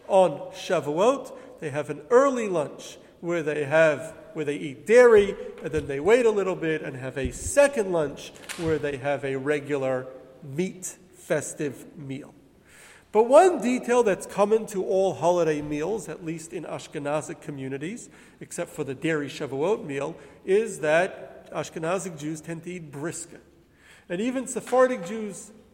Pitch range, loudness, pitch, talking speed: 150-215 Hz, -25 LUFS, 165 Hz, 155 wpm